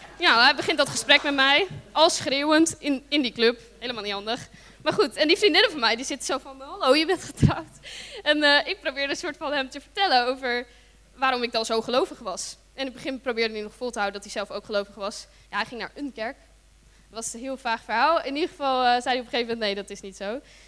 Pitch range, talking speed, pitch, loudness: 225-290 Hz, 265 wpm, 255 Hz, -24 LUFS